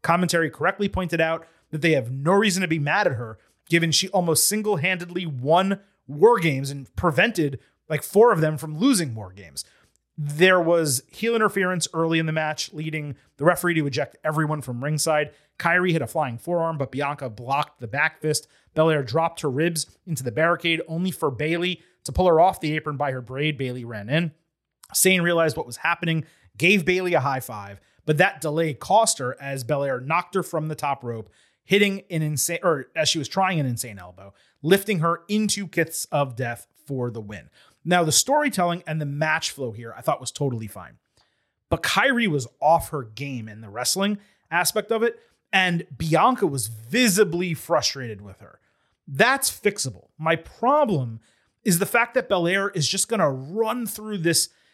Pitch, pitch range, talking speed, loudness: 160 Hz, 135-180 Hz, 185 wpm, -23 LUFS